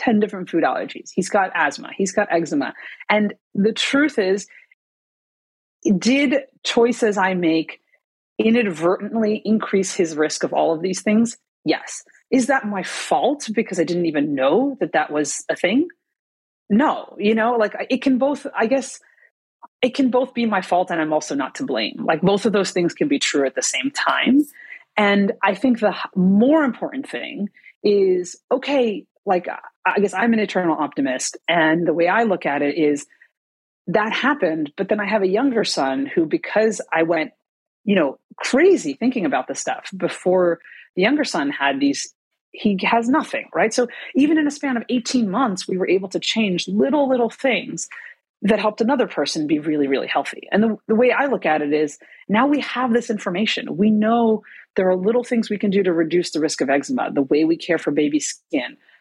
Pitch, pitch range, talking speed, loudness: 215 Hz, 180-260 Hz, 190 wpm, -20 LUFS